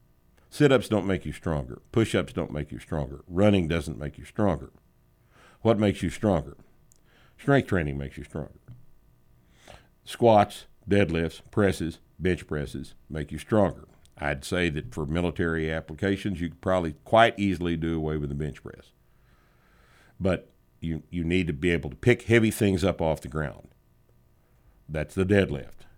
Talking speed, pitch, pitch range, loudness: 160 wpm, 85 Hz, 75-95 Hz, -27 LUFS